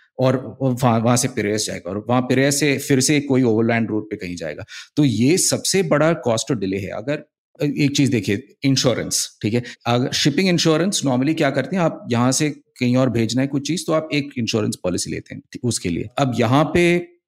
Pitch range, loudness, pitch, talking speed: 115-145 Hz, -19 LUFS, 130 Hz, 210 wpm